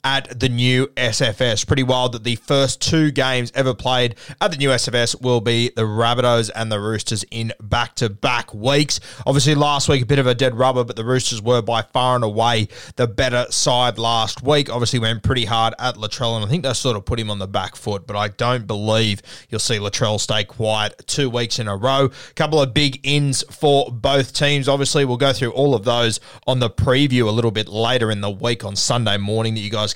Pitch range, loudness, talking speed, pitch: 110-135 Hz, -19 LUFS, 220 wpm, 120 Hz